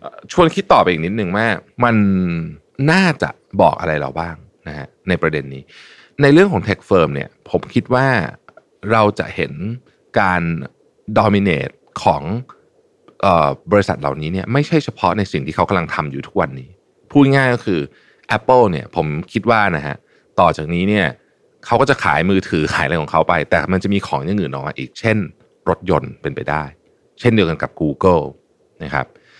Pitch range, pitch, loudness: 80-115 Hz, 95 Hz, -17 LUFS